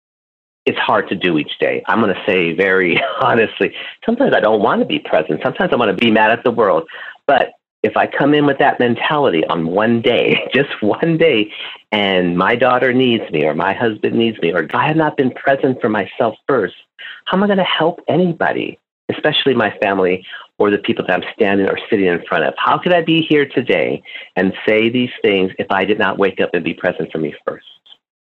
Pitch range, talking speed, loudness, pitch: 110-165 Hz, 220 wpm, -15 LUFS, 130 Hz